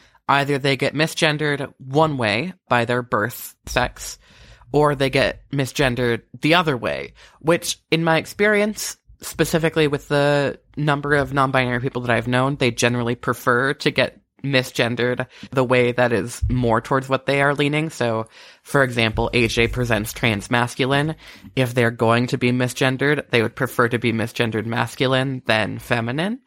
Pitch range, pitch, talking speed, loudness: 120-145 Hz, 130 Hz, 155 wpm, -20 LUFS